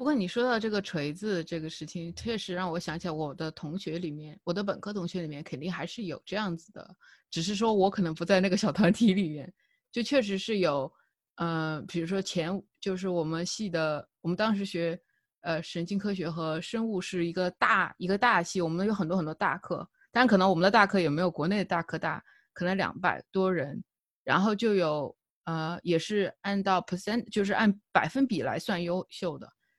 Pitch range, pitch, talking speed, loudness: 165-205 Hz, 185 Hz, 310 characters per minute, -29 LUFS